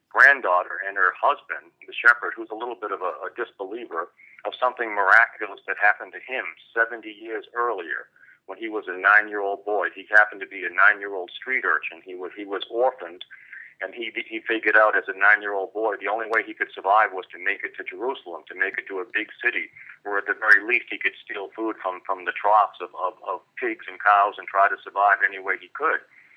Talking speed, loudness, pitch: 225 wpm, -22 LUFS, 345 Hz